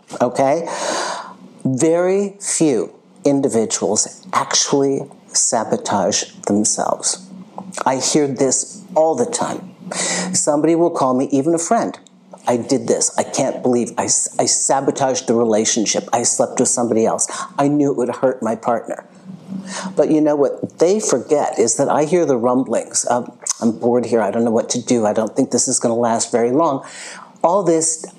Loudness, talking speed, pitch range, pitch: -17 LUFS, 165 wpm, 120-175 Hz, 140 Hz